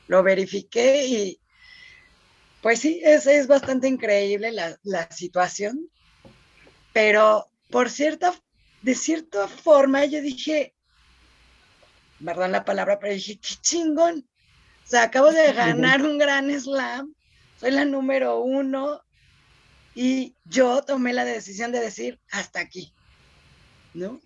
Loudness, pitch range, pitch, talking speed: -22 LUFS, 200-285 Hz, 255 Hz, 120 wpm